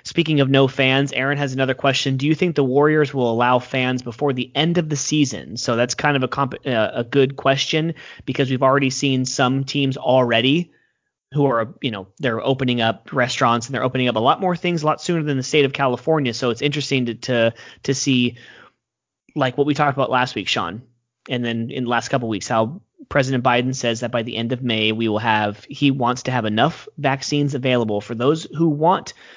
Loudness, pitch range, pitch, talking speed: -20 LUFS, 120-145 Hz, 130 Hz, 225 wpm